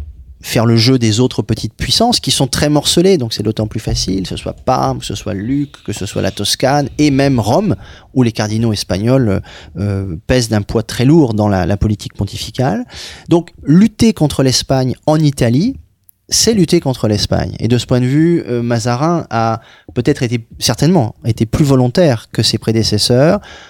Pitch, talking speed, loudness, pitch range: 120 Hz, 190 wpm, -14 LUFS, 105-140 Hz